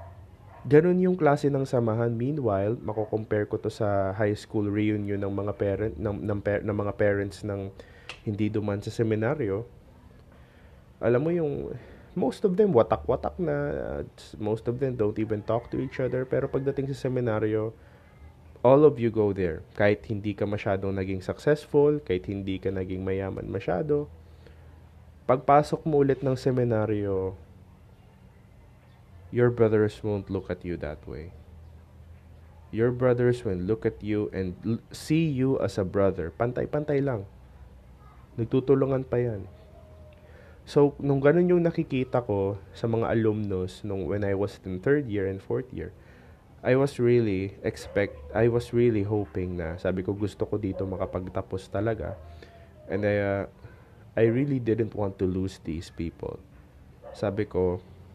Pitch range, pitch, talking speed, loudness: 95-120 Hz, 105 Hz, 150 wpm, -27 LUFS